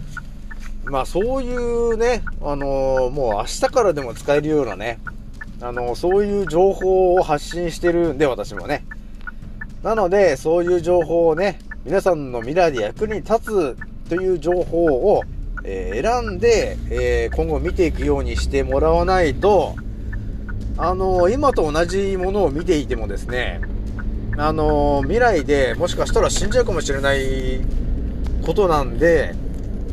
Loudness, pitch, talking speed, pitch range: -20 LUFS, 155 Hz, 285 characters per minute, 120-185 Hz